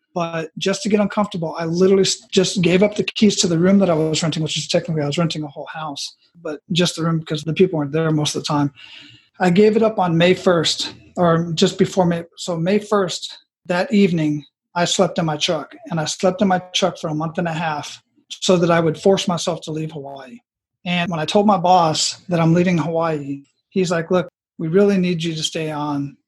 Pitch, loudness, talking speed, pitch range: 175 Hz, -19 LUFS, 235 wpm, 155-190 Hz